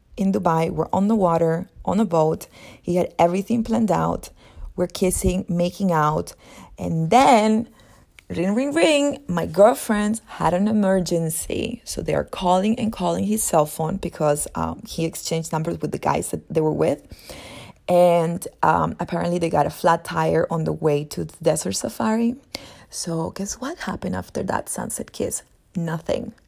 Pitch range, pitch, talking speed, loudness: 165-215 Hz, 175 Hz, 165 wpm, -22 LUFS